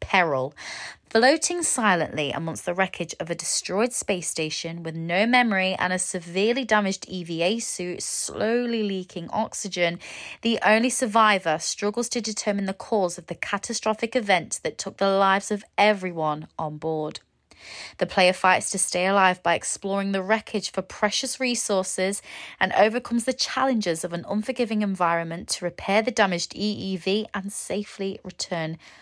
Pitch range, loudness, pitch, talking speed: 175-220 Hz, -24 LUFS, 195 Hz, 150 wpm